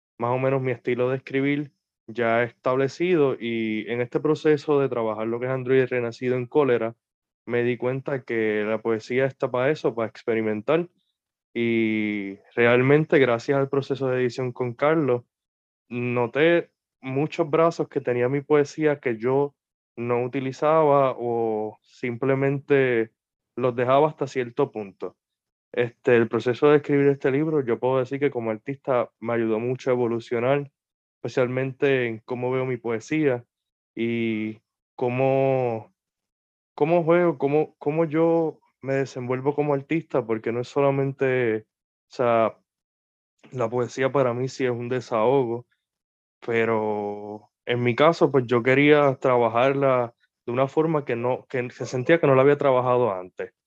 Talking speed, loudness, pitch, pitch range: 145 wpm, -23 LUFS, 125 Hz, 115-140 Hz